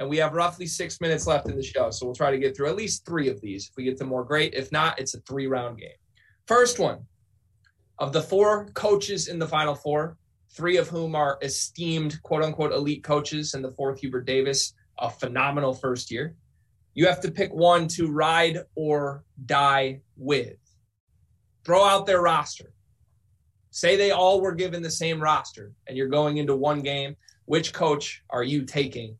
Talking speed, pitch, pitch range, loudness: 195 wpm, 145 Hz, 125-165 Hz, -25 LUFS